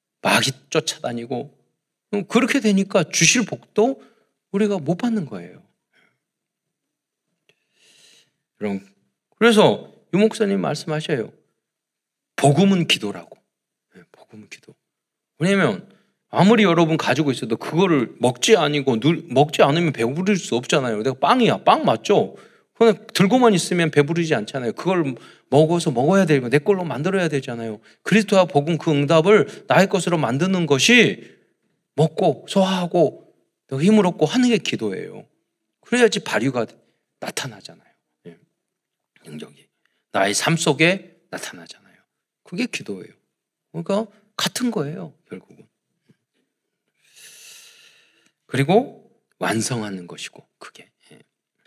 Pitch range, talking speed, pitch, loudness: 150-210 Hz, 265 characters per minute, 180 Hz, -19 LUFS